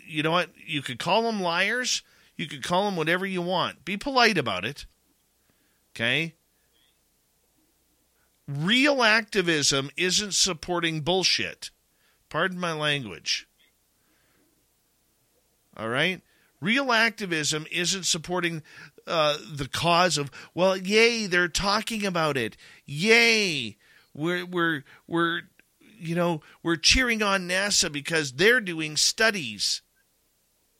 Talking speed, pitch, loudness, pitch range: 115 wpm, 175 Hz, -24 LUFS, 155-200 Hz